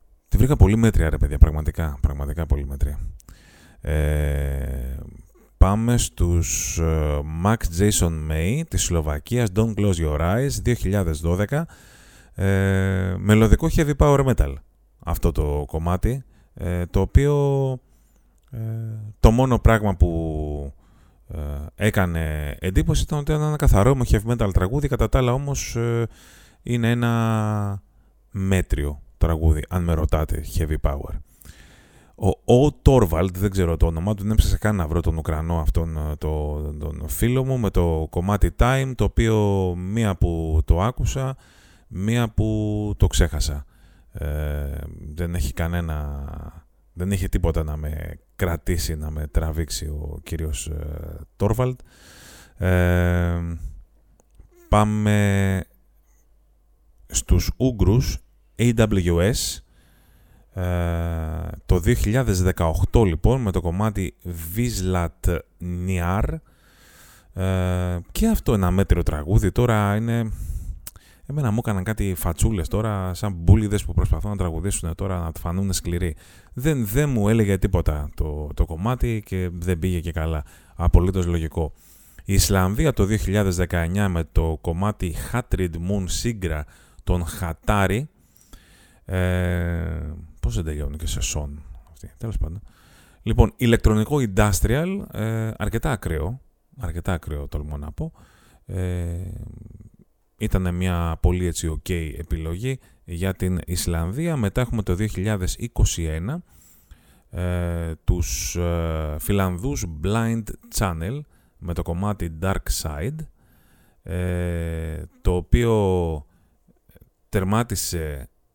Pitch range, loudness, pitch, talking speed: 80-105 Hz, -23 LUFS, 90 Hz, 115 wpm